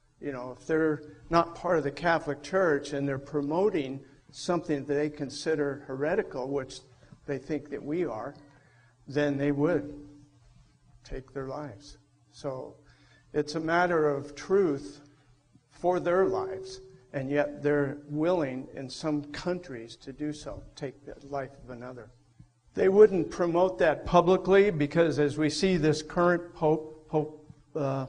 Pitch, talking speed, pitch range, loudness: 145 Hz, 145 wpm, 135-160 Hz, -28 LUFS